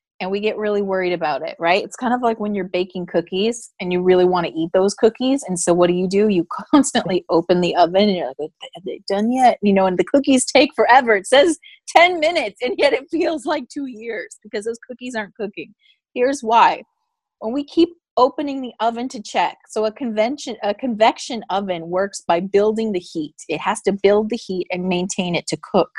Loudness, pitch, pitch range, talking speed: -19 LUFS, 215 Hz, 185-260 Hz, 225 wpm